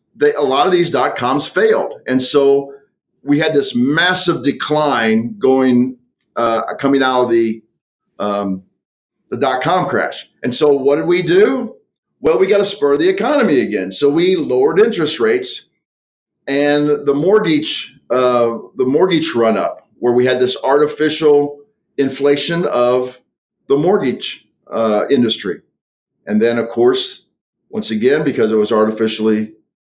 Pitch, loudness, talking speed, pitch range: 140 Hz, -15 LUFS, 150 wpm, 120-185 Hz